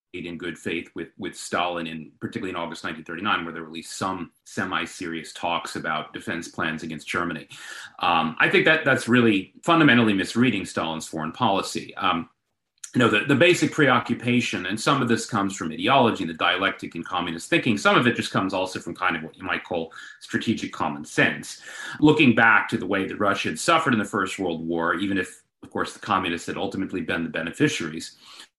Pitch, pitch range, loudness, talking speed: 100 Hz, 85-120 Hz, -23 LUFS, 200 wpm